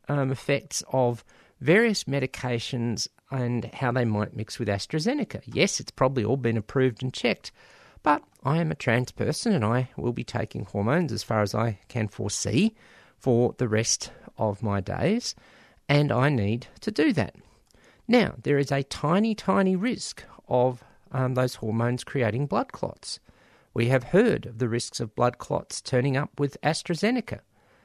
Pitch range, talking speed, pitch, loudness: 115-145 Hz, 165 wpm, 125 Hz, -26 LUFS